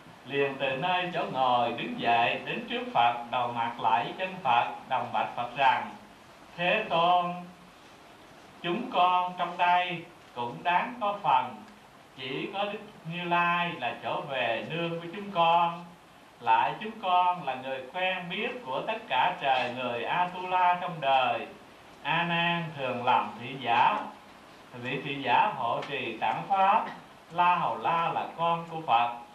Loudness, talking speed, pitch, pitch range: -28 LUFS, 160 wpm, 170 Hz, 130-180 Hz